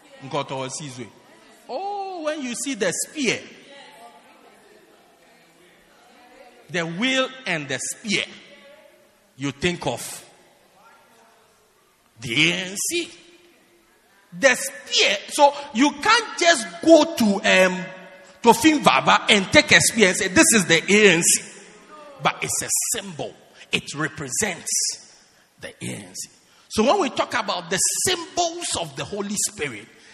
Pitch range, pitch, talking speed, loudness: 185-300 Hz, 215 Hz, 110 wpm, -20 LUFS